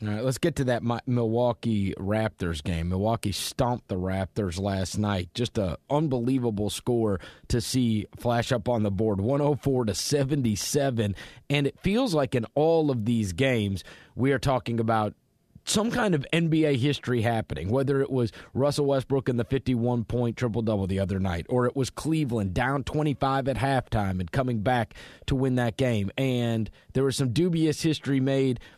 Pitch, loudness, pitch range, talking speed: 120 Hz, -27 LUFS, 105-135 Hz, 170 wpm